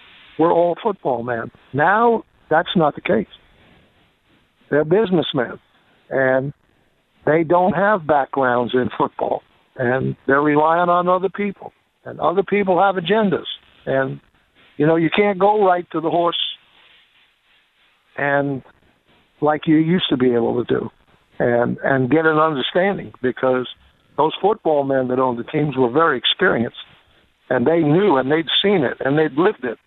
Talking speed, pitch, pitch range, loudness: 150 wpm, 155 Hz, 130-180 Hz, -18 LUFS